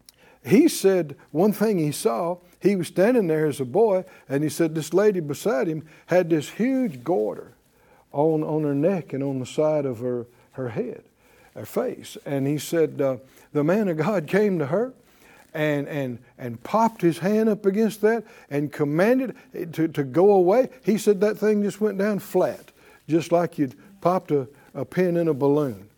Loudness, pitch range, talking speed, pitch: -23 LUFS, 145-200 Hz, 190 wpm, 165 Hz